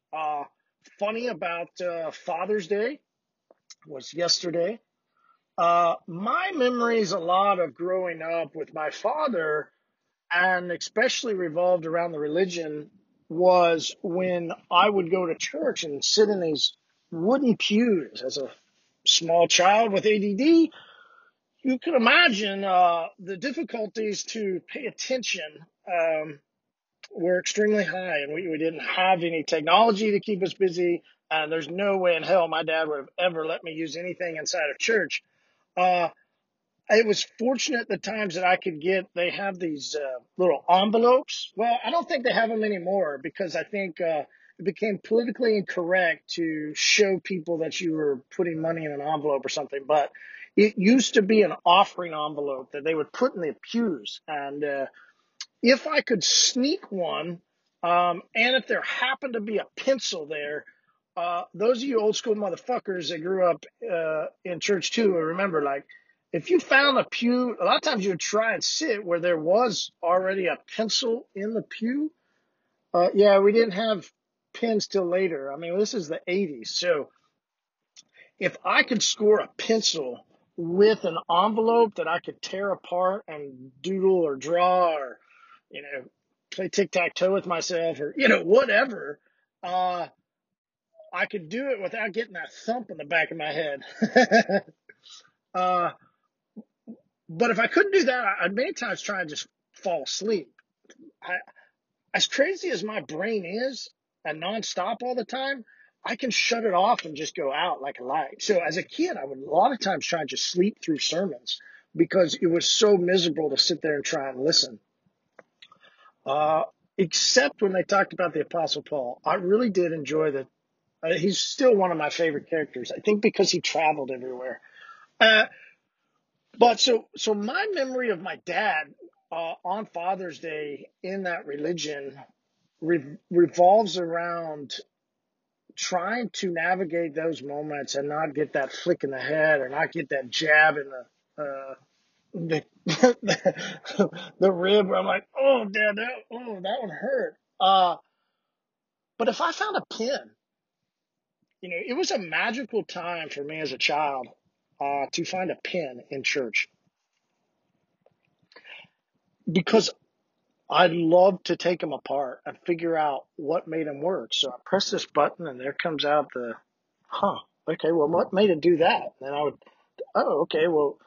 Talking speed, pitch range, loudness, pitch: 165 wpm, 165-225 Hz, -25 LUFS, 185 Hz